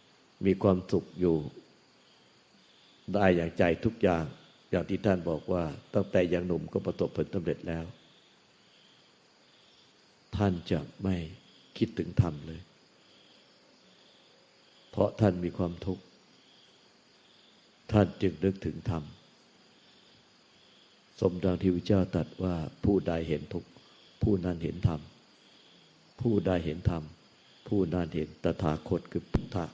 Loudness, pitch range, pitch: -31 LUFS, 80-95 Hz, 90 Hz